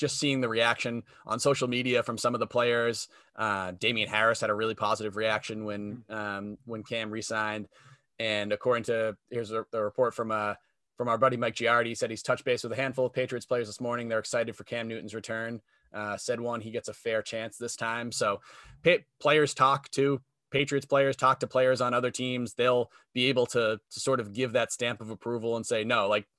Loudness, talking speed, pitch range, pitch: -29 LUFS, 220 wpm, 110-125 Hz, 120 Hz